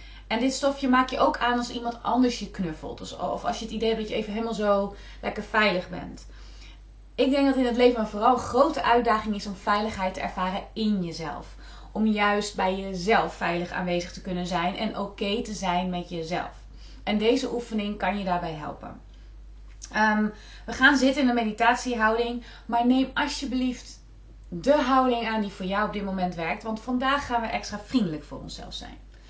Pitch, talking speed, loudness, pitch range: 215 Hz, 200 wpm, -26 LUFS, 190-240 Hz